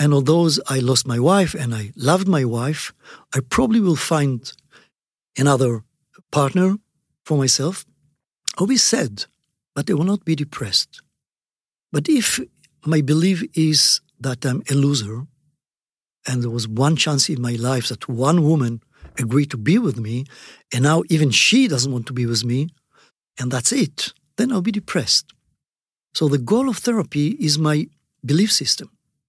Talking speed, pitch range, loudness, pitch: 160 wpm, 130-165 Hz, -19 LUFS, 145 Hz